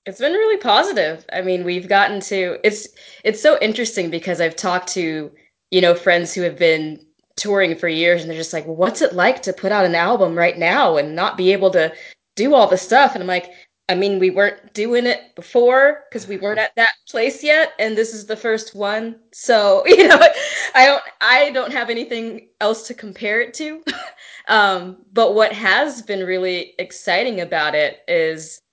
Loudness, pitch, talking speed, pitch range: -17 LUFS, 200 Hz, 200 wpm, 180-235 Hz